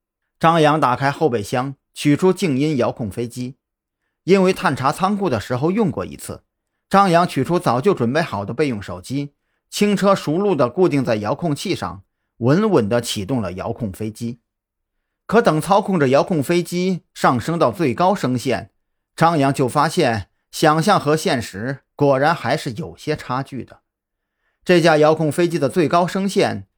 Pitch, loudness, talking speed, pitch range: 140 Hz, -18 LUFS, 245 characters per minute, 115-170 Hz